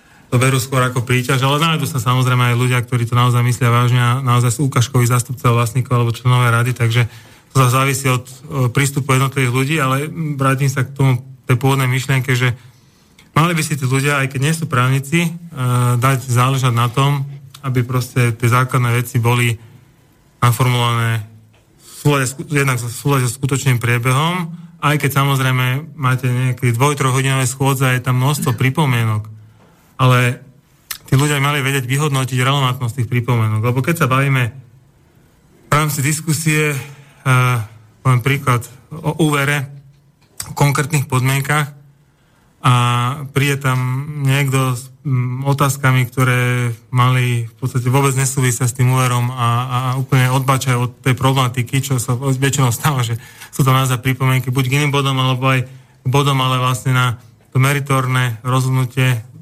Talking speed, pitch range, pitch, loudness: 155 wpm, 125-140 Hz, 130 Hz, -16 LUFS